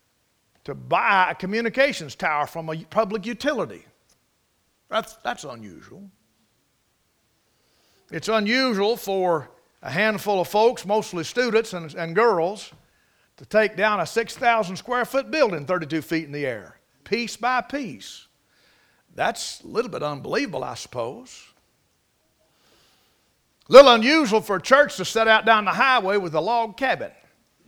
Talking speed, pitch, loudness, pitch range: 135 wpm, 215 Hz, -21 LUFS, 185-240 Hz